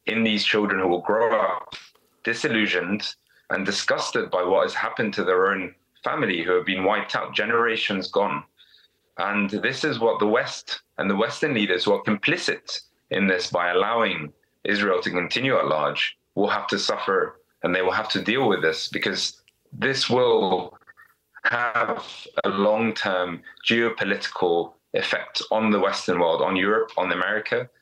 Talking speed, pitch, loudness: 165 wpm, 115 Hz, -23 LUFS